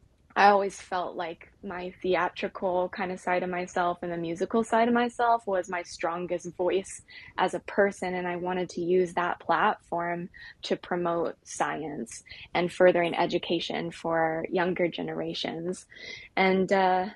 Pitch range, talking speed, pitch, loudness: 175-185 Hz, 145 wpm, 180 Hz, -28 LUFS